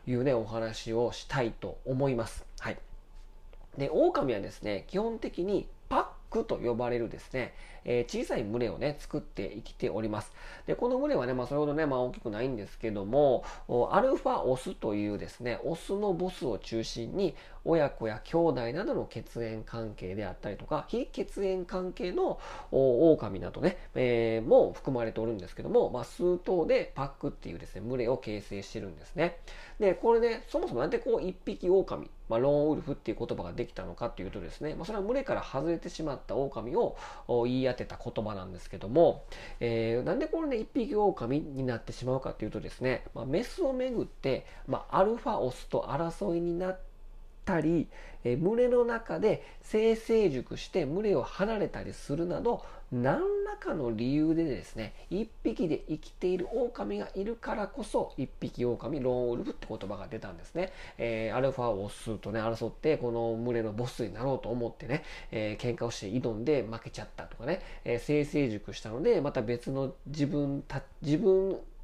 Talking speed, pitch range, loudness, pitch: 370 characters per minute, 115-175 Hz, -32 LUFS, 130 Hz